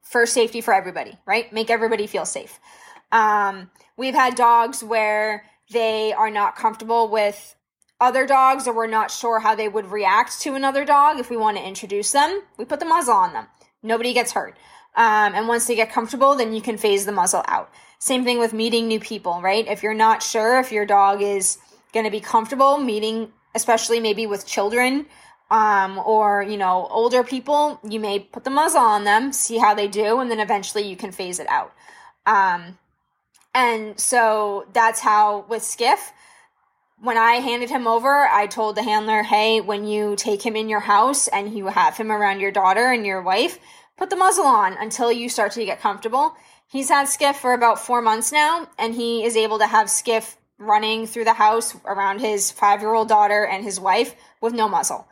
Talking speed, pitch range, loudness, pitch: 200 wpm, 210-250 Hz, -19 LUFS, 225 Hz